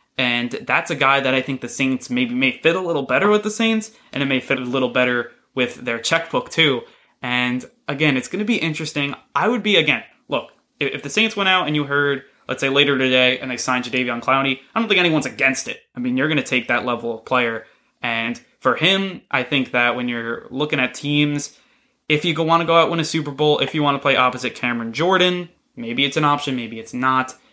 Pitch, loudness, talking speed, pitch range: 140 Hz, -19 LUFS, 235 wpm, 125-165 Hz